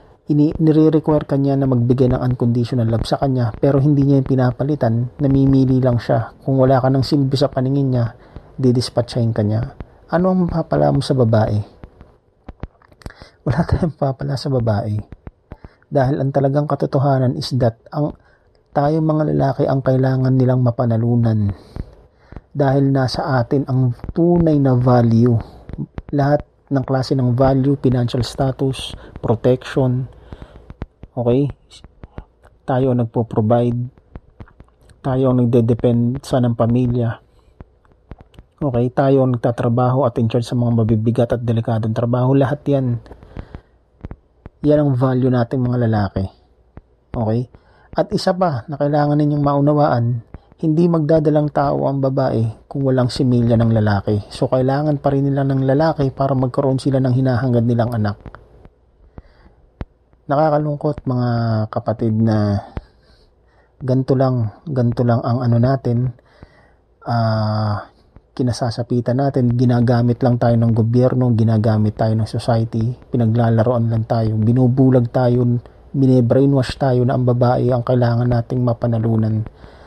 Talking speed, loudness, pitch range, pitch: 125 wpm, -17 LUFS, 115-135 Hz, 125 Hz